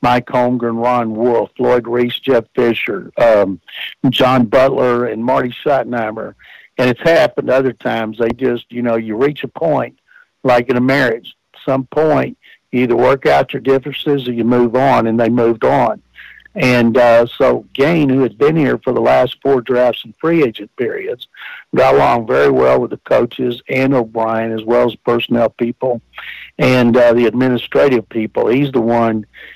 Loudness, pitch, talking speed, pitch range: -14 LUFS, 125 Hz, 175 wpm, 115-130 Hz